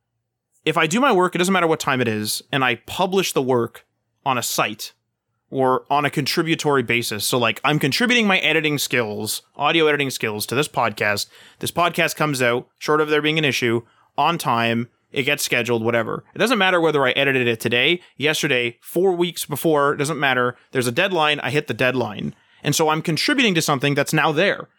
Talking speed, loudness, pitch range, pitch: 205 wpm, -19 LUFS, 120-160 Hz, 145 Hz